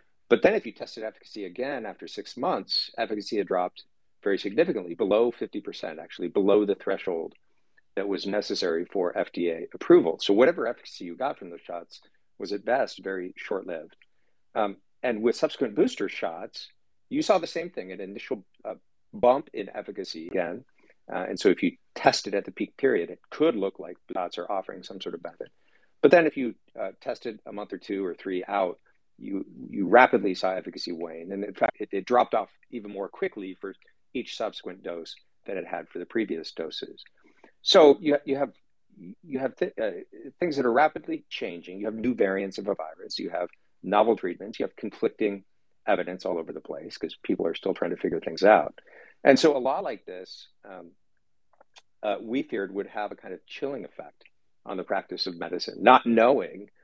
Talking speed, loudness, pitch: 195 wpm, -27 LUFS, 110 Hz